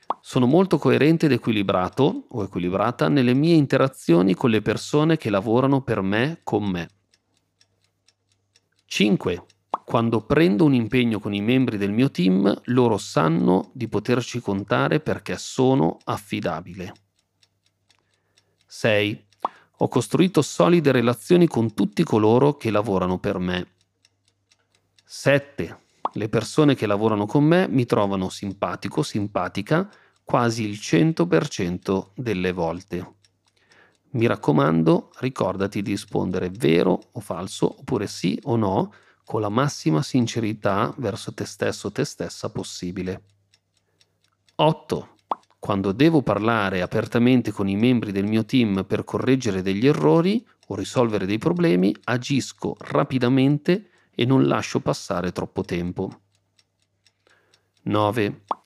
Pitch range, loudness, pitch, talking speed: 95-130 Hz, -22 LUFS, 105 Hz, 120 wpm